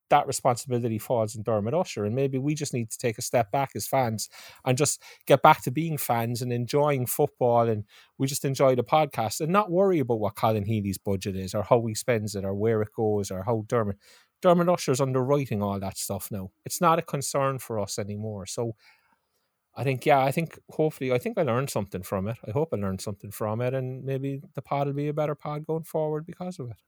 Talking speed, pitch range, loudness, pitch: 230 wpm, 110-145 Hz, -27 LUFS, 125 Hz